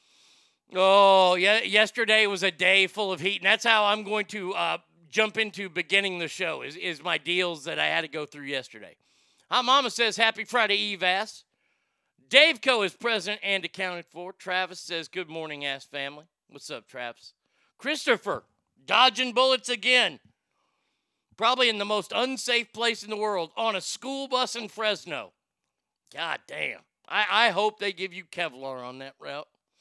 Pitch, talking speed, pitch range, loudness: 200 Hz, 170 wpm, 180-230 Hz, -24 LUFS